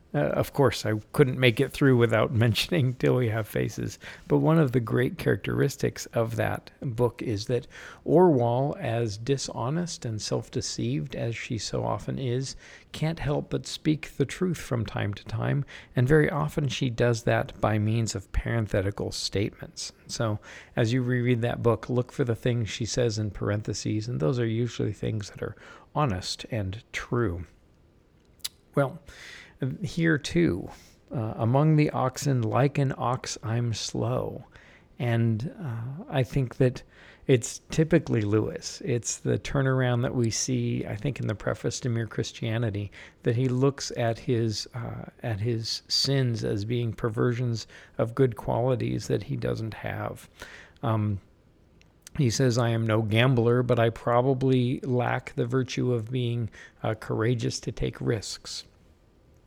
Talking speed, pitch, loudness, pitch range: 155 wpm, 120 Hz, -27 LUFS, 110-130 Hz